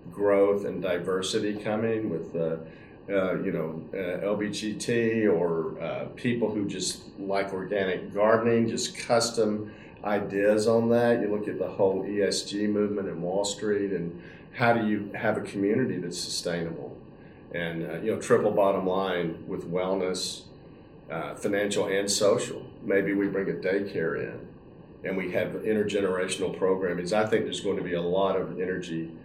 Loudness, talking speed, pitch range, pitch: -27 LUFS, 160 wpm, 95-105 Hz, 100 Hz